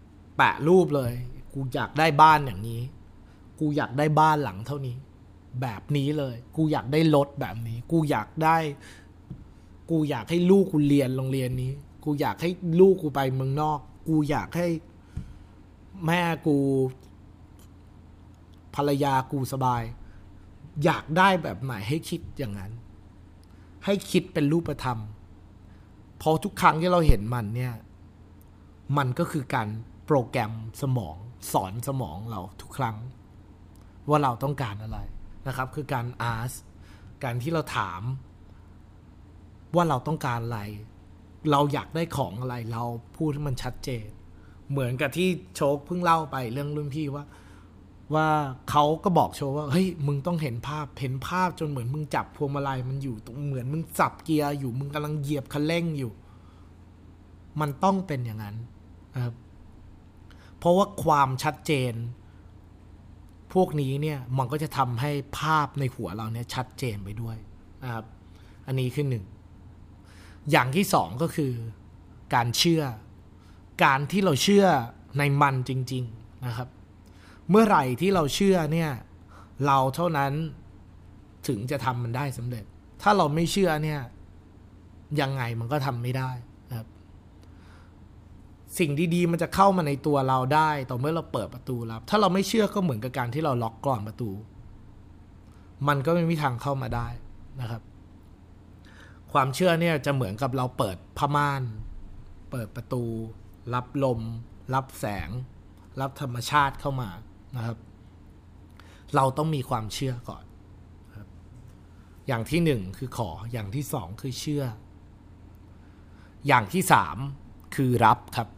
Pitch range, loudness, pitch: 95-145 Hz, -26 LUFS, 125 Hz